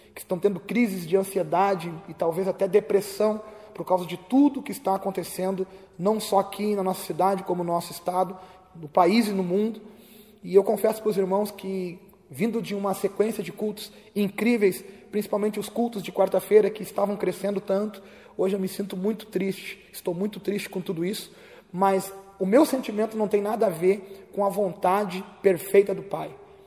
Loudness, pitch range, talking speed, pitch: -25 LUFS, 190-210 Hz, 185 wpm, 195 Hz